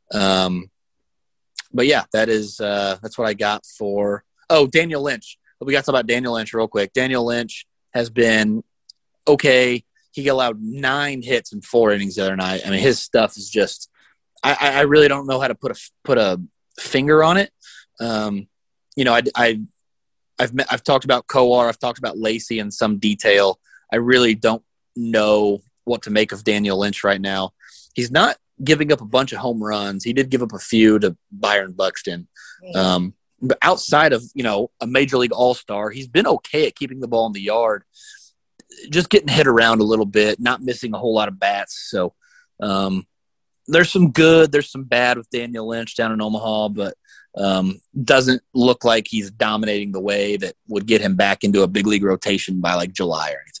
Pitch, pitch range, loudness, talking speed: 115 Hz, 105-130 Hz, -18 LUFS, 200 wpm